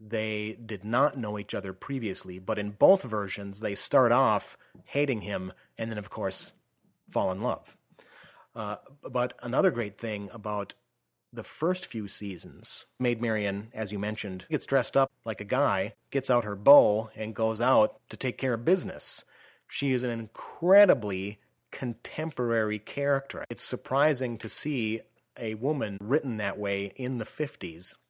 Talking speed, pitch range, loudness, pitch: 160 wpm, 105-130 Hz, -29 LUFS, 110 Hz